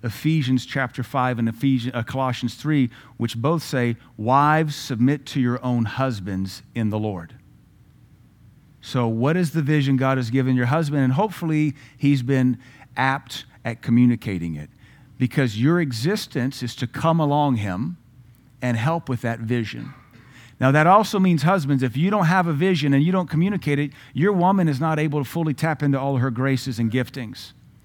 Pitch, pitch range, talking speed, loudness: 135 Hz, 120-150 Hz, 175 wpm, -22 LUFS